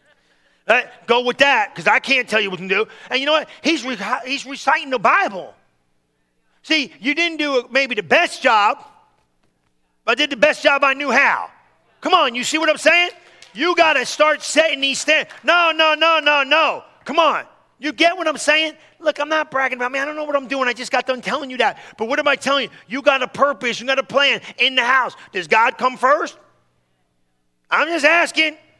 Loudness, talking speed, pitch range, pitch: -17 LUFS, 225 wpm, 255-310 Hz, 280 Hz